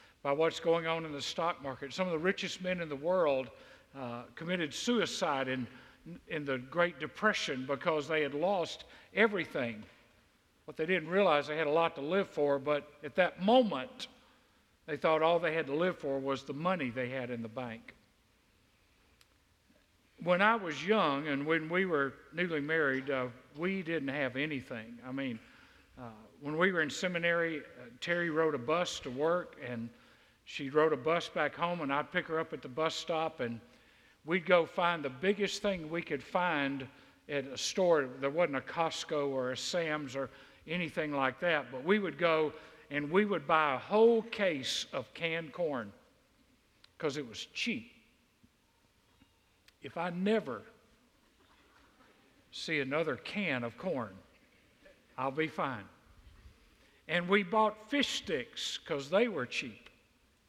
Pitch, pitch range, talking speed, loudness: 155 Hz, 135-175 Hz, 165 wpm, -33 LUFS